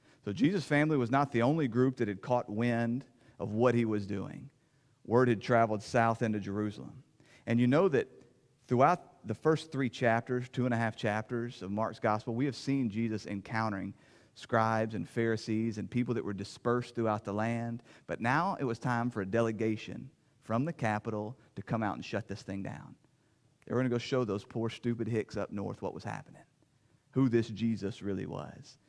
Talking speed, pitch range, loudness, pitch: 195 wpm, 110-125 Hz, -32 LUFS, 115 Hz